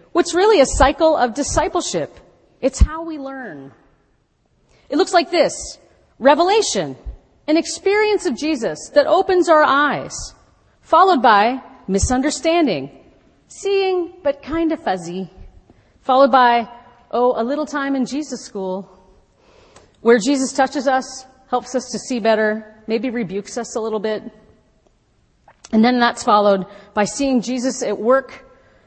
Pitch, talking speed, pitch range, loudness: 265 Hz, 135 wpm, 230-315 Hz, -17 LUFS